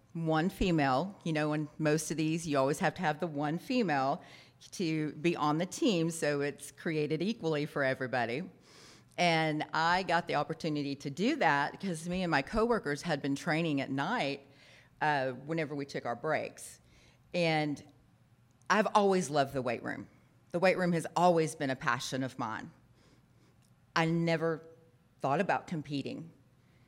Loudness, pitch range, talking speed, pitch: -32 LUFS, 140-170 Hz, 165 wpm, 155 Hz